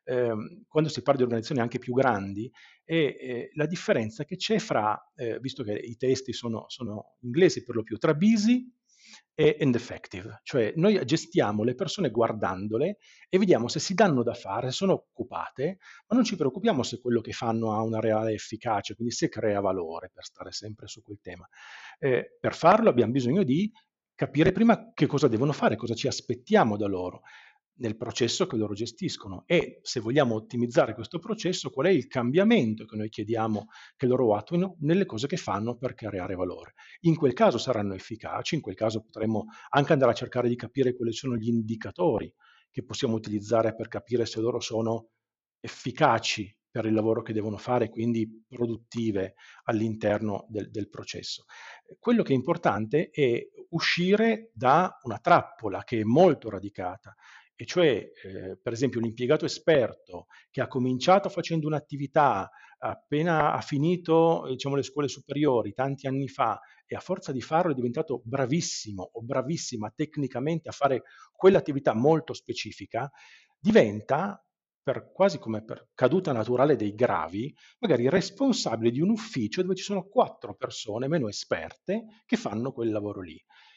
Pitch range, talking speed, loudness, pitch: 110-165 Hz, 165 wpm, -27 LUFS, 125 Hz